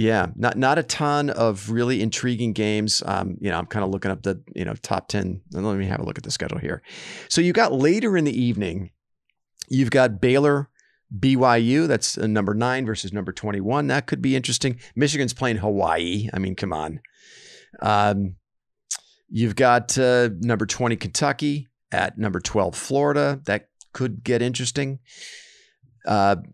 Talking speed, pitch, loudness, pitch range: 175 wpm, 115 Hz, -22 LUFS, 100-130 Hz